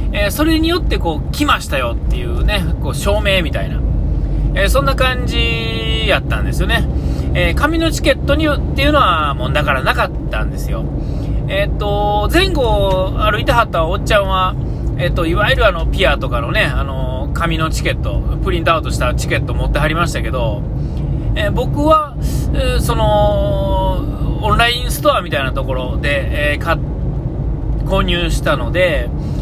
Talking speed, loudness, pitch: 290 characters per minute, -16 LUFS, 70 Hz